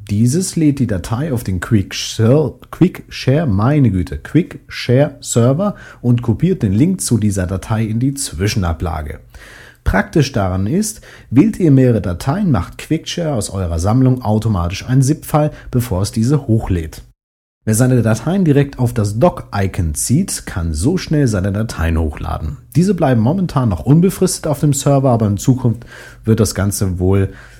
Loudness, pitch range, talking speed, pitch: -16 LUFS, 100-145 Hz, 155 wpm, 120 Hz